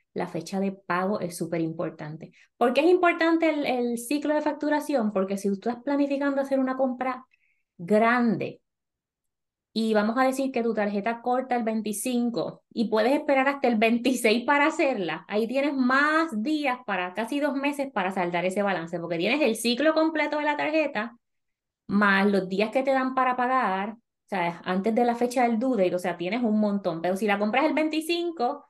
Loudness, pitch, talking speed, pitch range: -25 LUFS, 235 Hz, 190 wpm, 195-275 Hz